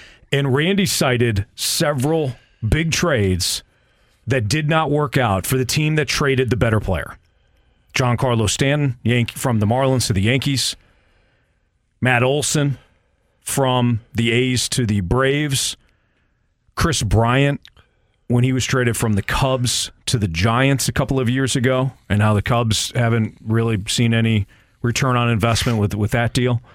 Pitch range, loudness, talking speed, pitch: 110-135 Hz, -19 LUFS, 155 wpm, 120 Hz